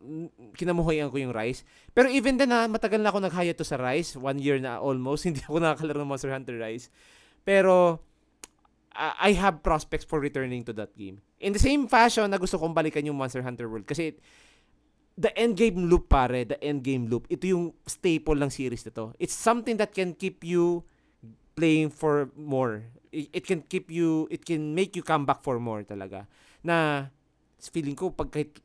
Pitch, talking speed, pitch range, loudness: 155 Hz, 190 wpm, 135-180 Hz, -27 LUFS